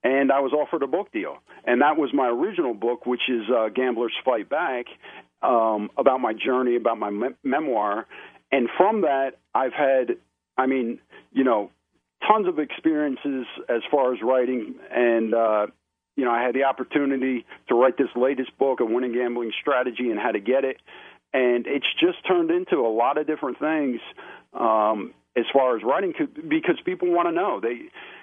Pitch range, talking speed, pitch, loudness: 120-155 Hz, 185 wpm, 130 Hz, -23 LUFS